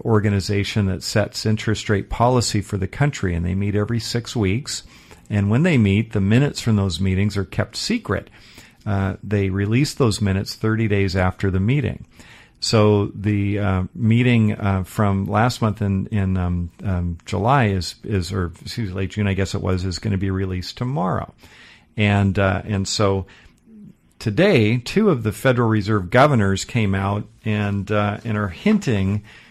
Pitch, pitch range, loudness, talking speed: 105 Hz, 95-110 Hz, -20 LUFS, 175 wpm